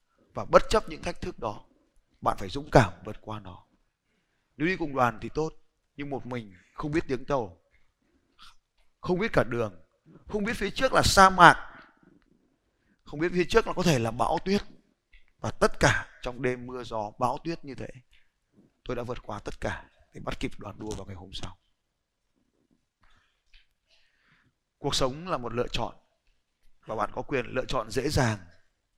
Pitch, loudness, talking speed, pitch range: 130 Hz, -27 LUFS, 180 wpm, 115-165 Hz